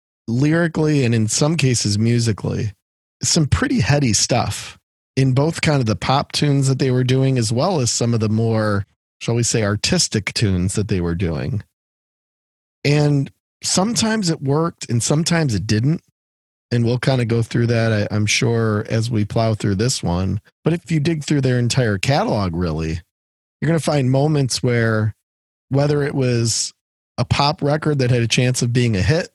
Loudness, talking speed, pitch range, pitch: -18 LUFS, 180 wpm, 105-145 Hz, 120 Hz